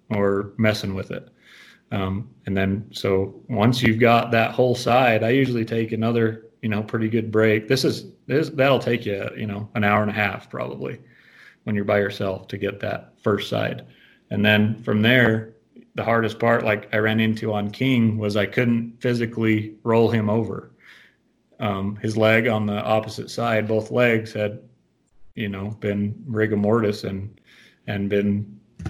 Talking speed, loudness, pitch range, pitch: 175 wpm, -22 LUFS, 105-115 Hz, 110 Hz